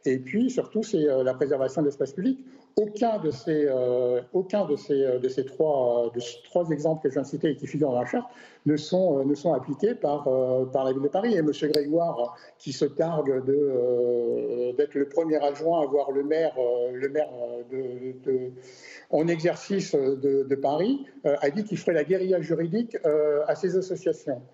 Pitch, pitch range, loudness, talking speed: 145 Hz, 130-170 Hz, -26 LUFS, 215 wpm